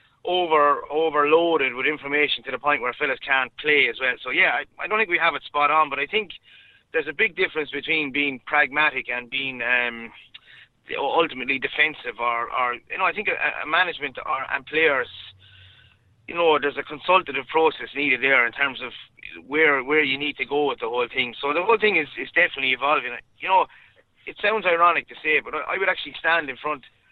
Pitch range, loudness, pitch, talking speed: 125-160 Hz, -22 LUFS, 145 Hz, 210 wpm